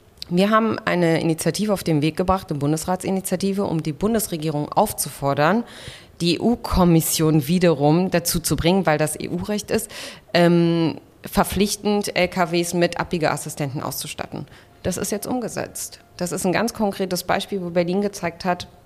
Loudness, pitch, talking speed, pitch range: -21 LUFS, 175 Hz, 145 wpm, 160-195 Hz